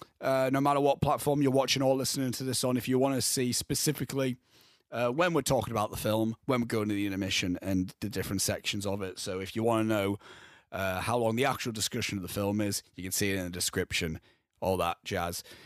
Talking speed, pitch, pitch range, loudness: 240 wpm, 115 Hz, 100-130 Hz, -30 LUFS